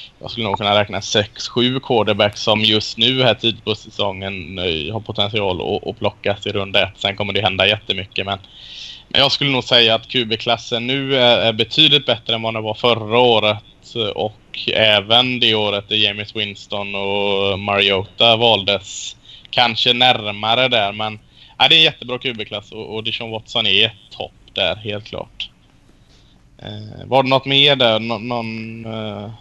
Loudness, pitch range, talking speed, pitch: -16 LUFS, 100-120 Hz, 170 wpm, 110 Hz